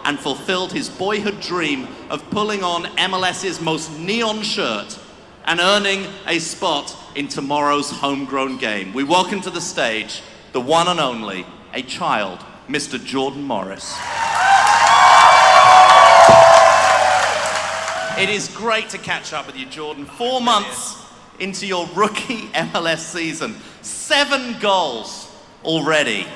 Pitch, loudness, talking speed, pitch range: 180 Hz, -16 LUFS, 120 wpm, 145-205 Hz